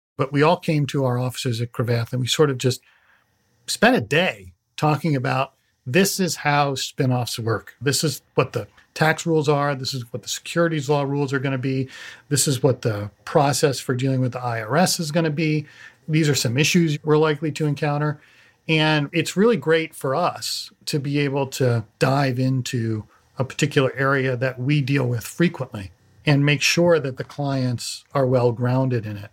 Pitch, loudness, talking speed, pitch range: 140 Hz, -21 LUFS, 195 wpm, 125-155 Hz